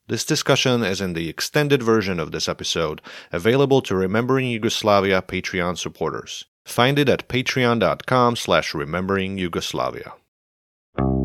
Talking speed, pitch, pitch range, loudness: 125 wpm, 105 Hz, 90-125 Hz, -21 LUFS